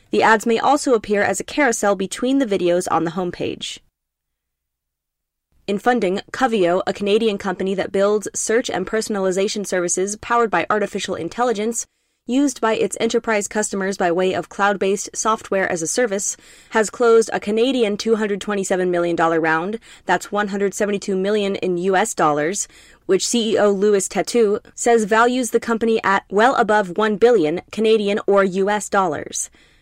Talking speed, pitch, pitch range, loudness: 145 wpm, 200 Hz, 185-225 Hz, -19 LUFS